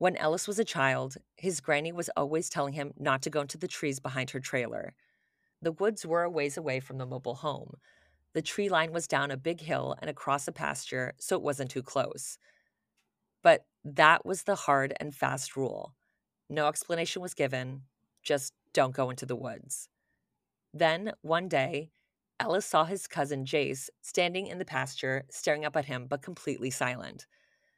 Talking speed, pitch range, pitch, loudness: 180 wpm, 135-170 Hz, 150 Hz, -31 LUFS